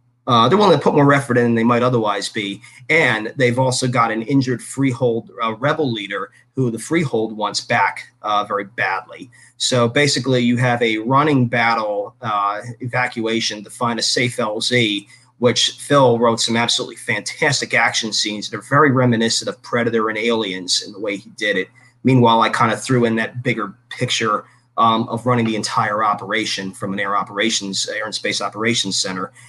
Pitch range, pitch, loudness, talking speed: 110-125 Hz, 120 Hz, -18 LUFS, 185 wpm